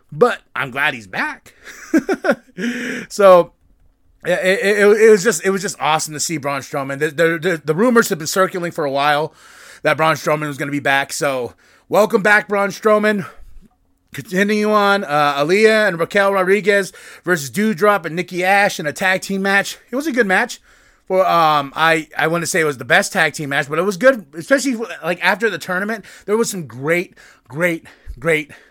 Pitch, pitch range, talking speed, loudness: 185 Hz, 155-205 Hz, 195 wpm, -16 LUFS